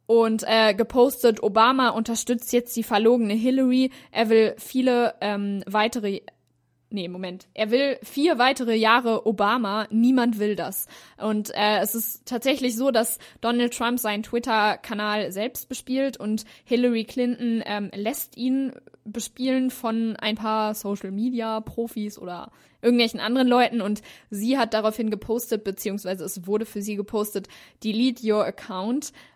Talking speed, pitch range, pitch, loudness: 140 wpm, 210-245 Hz, 225 Hz, -24 LUFS